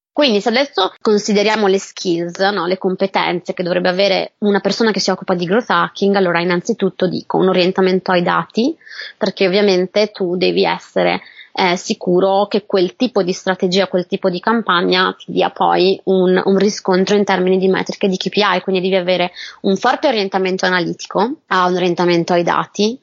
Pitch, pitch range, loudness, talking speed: 190 Hz, 185-205 Hz, -16 LUFS, 175 wpm